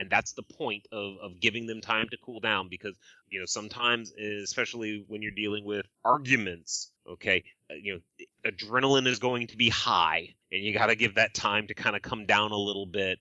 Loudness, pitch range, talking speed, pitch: -28 LUFS, 105-120 Hz, 210 wpm, 105 Hz